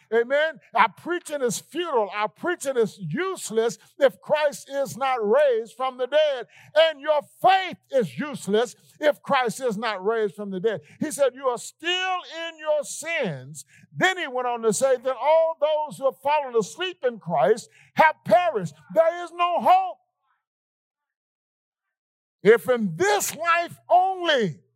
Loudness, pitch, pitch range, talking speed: -23 LUFS, 275 Hz, 225-330 Hz, 155 wpm